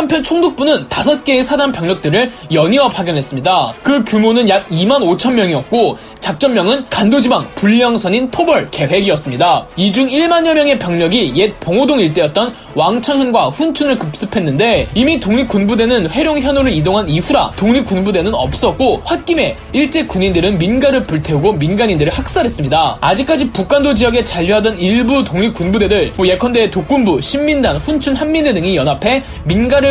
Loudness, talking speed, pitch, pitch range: -13 LUFS, 375 characters per minute, 240 Hz, 190-280 Hz